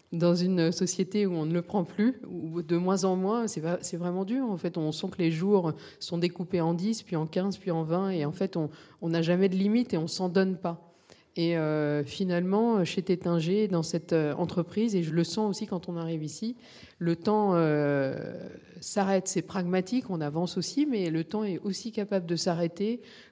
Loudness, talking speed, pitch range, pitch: -29 LUFS, 210 wpm, 170-200 Hz, 180 Hz